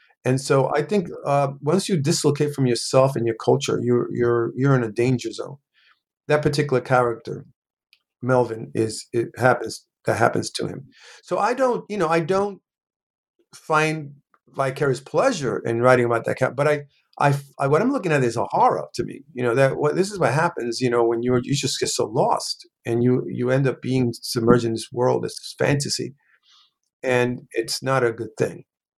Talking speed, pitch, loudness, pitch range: 195 wpm, 130 Hz, -22 LUFS, 120-150 Hz